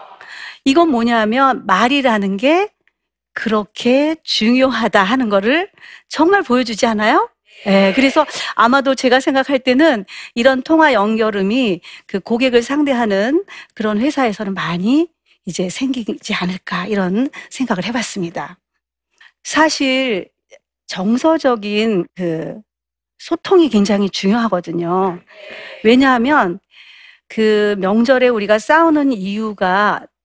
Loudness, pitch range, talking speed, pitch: -15 LUFS, 205-280 Hz, 245 characters per minute, 235 Hz